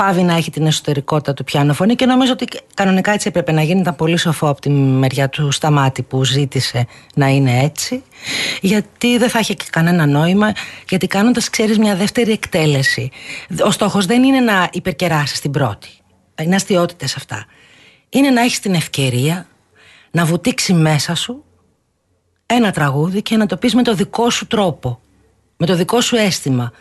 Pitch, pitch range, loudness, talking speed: 170 Hz, 140-210 Hz, -15 LUFS, 175 wpm